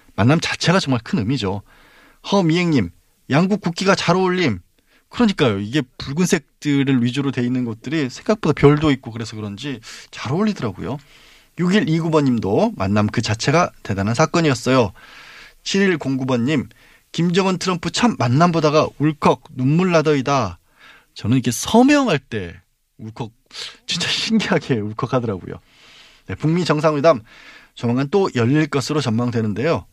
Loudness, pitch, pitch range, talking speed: -19 LUFS, 140 Hz, 120-170 Hz, 310 characters per minute